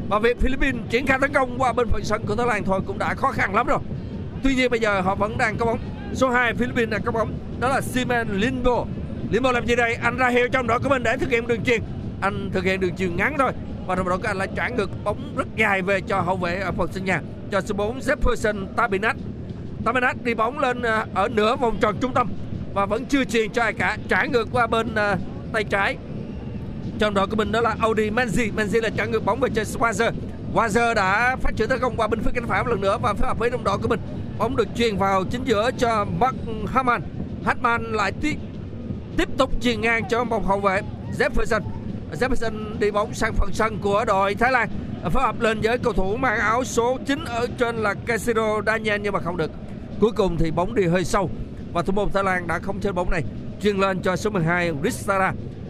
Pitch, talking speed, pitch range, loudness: 220 Hz, 240 wpm, 195-240 Hz, -23 LUFS